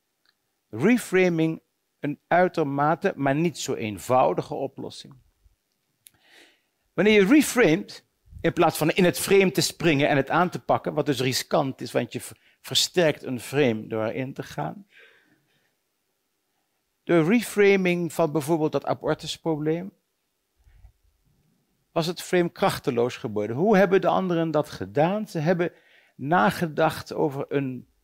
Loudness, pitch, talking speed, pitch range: -24 LUFS, 160 Hz, 125 wpm, 140-180 Hz